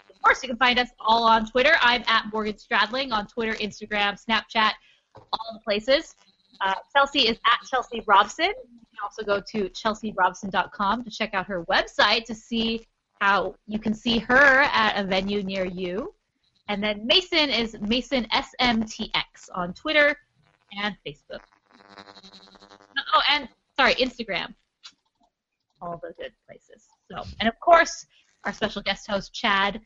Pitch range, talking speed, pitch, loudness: 200-255 Hz, 155 wpm, 220 Hz, -23 LUFS